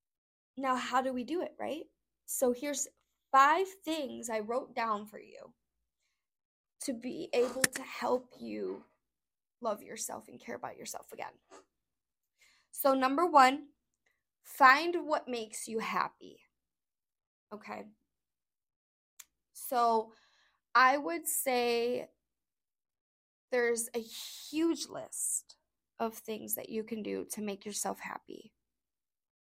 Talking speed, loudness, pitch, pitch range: 115 wpm, -32 LUFS, 255 Hz, 225-290 Hz